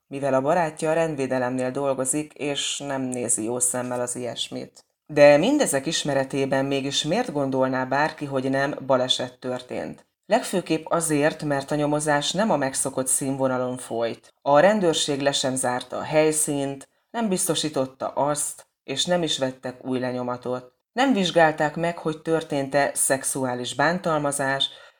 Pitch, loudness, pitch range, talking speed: 140 Hz, -23 LUFS, 130-155 Hz, 135 wpm